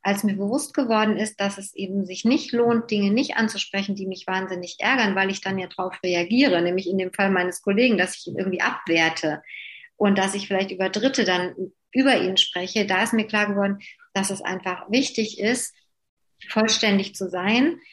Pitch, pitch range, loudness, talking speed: 200 Hz, 185-225 Hz, -23 LUFS, 195 wpm